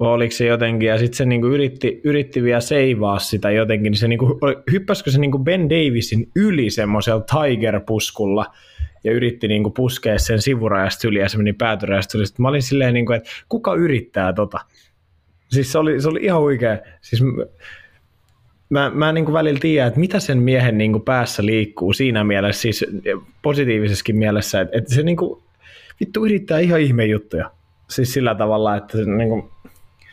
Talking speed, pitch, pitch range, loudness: 170 wpm, 115 Hz, 105-140 Hz, -18 LUFS